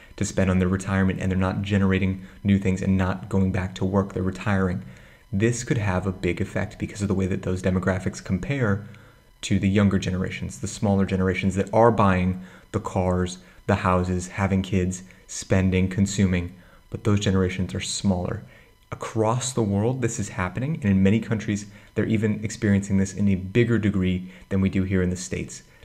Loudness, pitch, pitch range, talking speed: -24 LUFS, 95 Hz, 95-105 Hz, 190 wpm